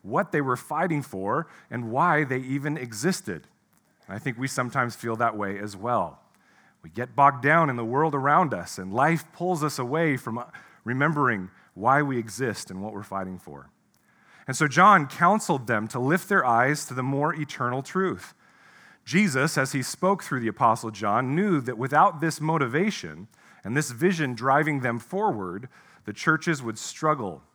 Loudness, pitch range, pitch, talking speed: -25 LUFS, 120-160 Hz, 135 Hz, 175 wpm